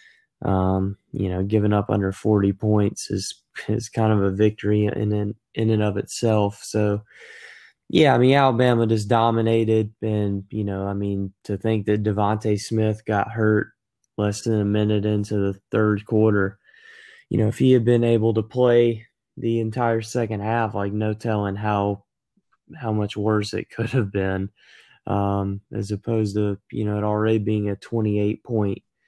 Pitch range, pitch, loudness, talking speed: 100-110 Hz, 105 Hz, -22 LUFS, 175 wpm